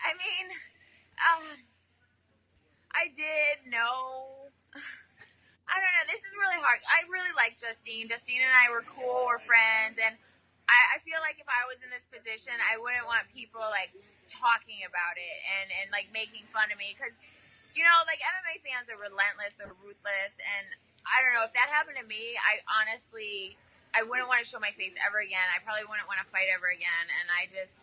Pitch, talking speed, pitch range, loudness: 230 Hz, 195 wpm, 200-285 Hz, -28 LUFS